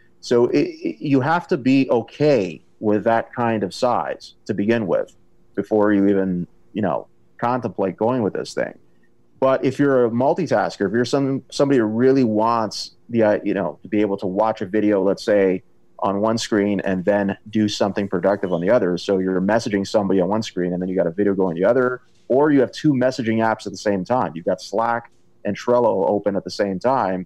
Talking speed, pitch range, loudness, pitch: 215 wpm, 95-120 Hz, -20 LUFS, 105 Hz